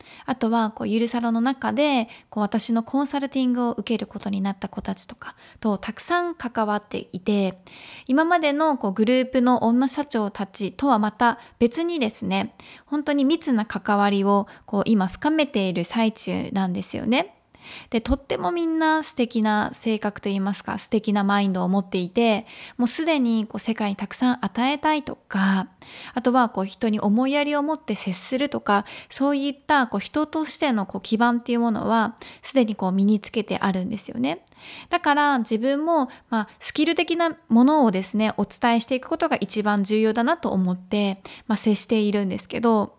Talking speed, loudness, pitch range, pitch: 365 characters per minute, -23 LUFS, 205-270 Hz, 230 Hz